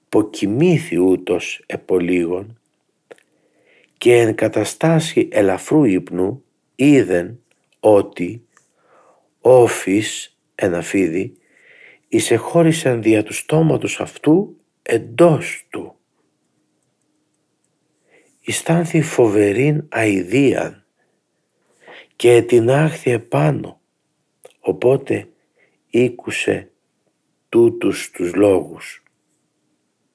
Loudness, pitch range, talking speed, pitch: -17 LUFS, 105-165 Hz, 60 wpm, 135 Hz